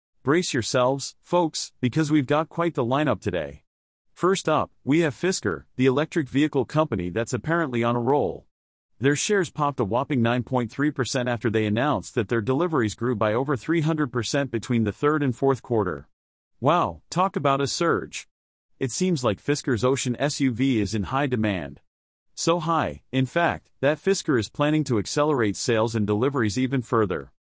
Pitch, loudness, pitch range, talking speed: 130 Hz, -24 LUFS, 115-150 Hz, 165 wpm